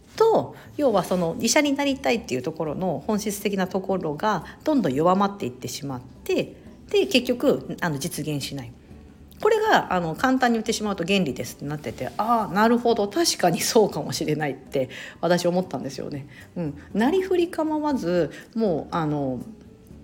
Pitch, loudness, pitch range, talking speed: 195 Hz, -24 LUFS, 150-250 Hz, 325 characters per minute